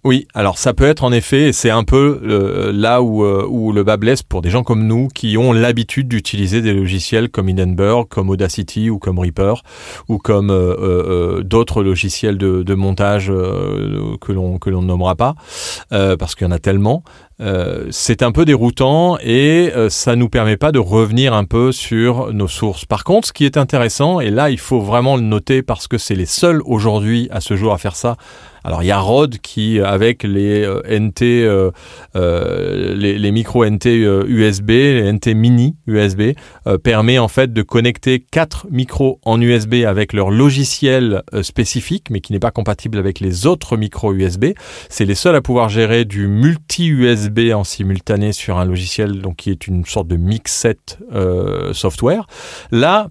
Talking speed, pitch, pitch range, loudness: 195 wpm, 110 Hz, 100-125 Hz, -15 LUFS